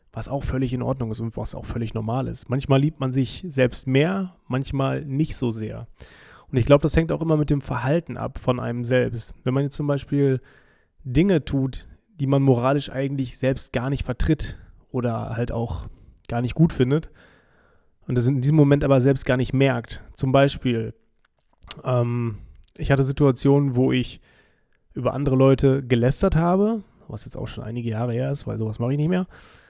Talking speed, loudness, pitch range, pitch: 190 wpm, -23 LUFS, 120-140 Hz, 130 Hz